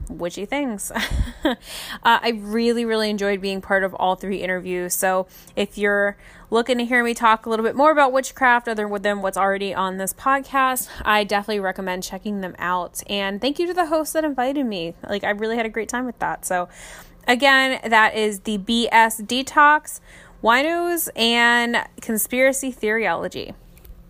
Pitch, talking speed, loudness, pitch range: 220 Hz, 170 wpm, -20 LUFS, 195-250 Hz